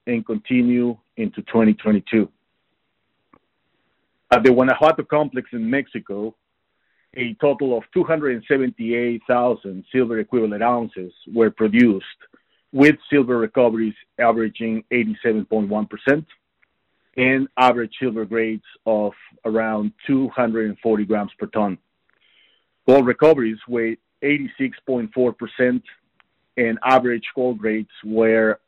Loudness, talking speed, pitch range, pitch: -20 LUFS, 90 wpm, 110-130 Hz, 120 Hz